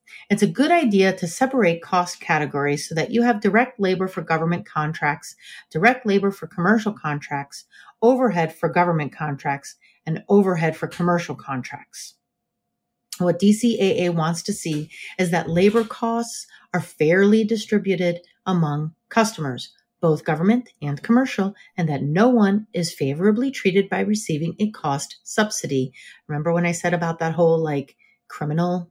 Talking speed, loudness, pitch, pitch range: 145 wpm, -21 LUFS, 175 Hz, 160-210 Hz